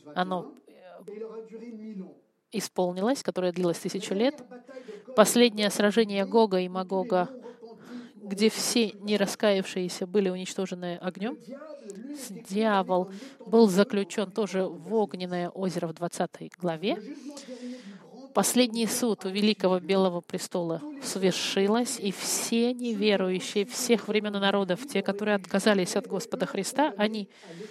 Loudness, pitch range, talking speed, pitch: -27 LUFS, 185-230 Hz, 105 wpm, 205 Hz